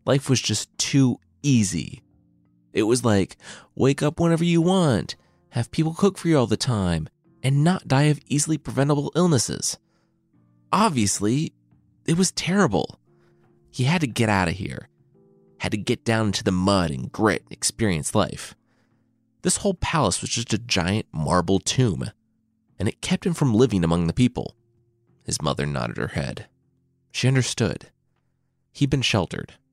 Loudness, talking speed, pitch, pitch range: -23 LUFS, 160 wpm, 120 Hz, 100-145 Hz